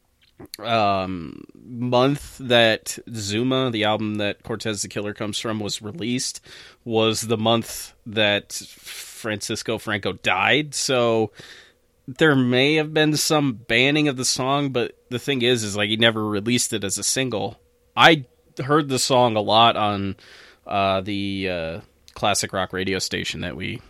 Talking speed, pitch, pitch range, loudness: 150 wpm, 115 Hz, 105-130 Hz, -21 LUFS